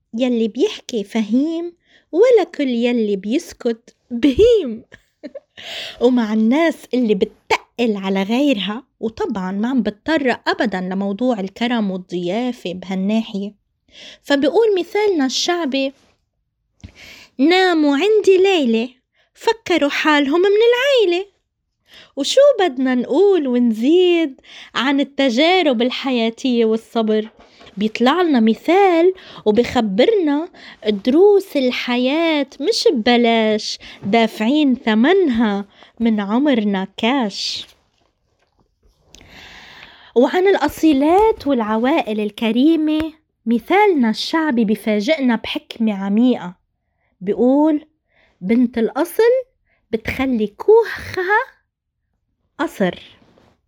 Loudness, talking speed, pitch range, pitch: -17 LUFS, 75 wpm, 225-320 Hz, 260 Hz